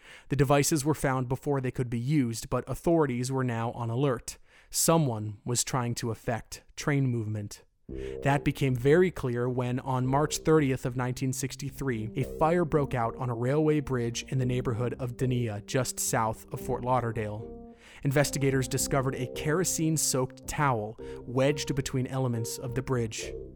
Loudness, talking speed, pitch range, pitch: -29 LUFS, 155 wpm, 120-140 Hz, 130 Hz